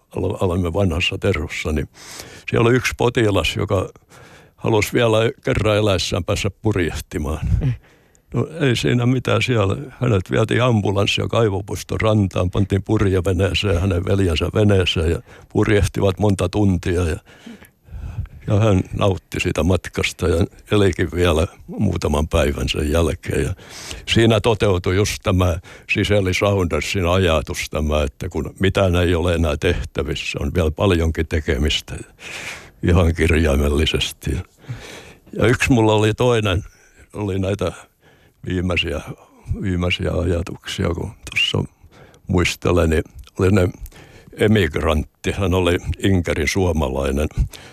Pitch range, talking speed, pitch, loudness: 85-105 Hz, 115 wpm, 95 Hz, -19 LUFS